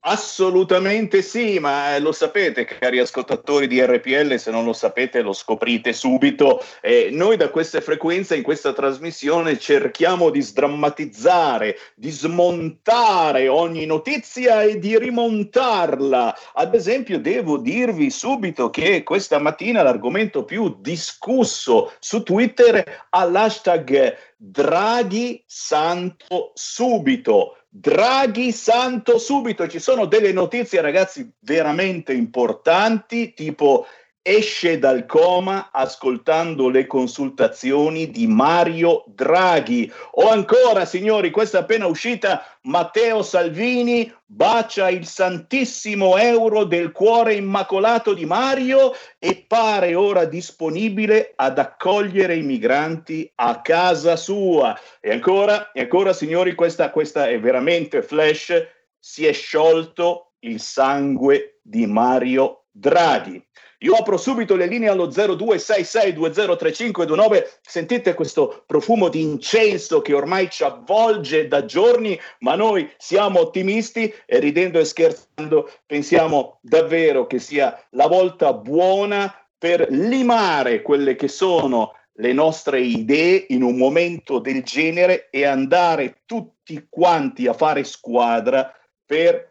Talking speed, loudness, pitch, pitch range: 115 wpm, -18 LUFS, 185 Hz, 160-235 Hz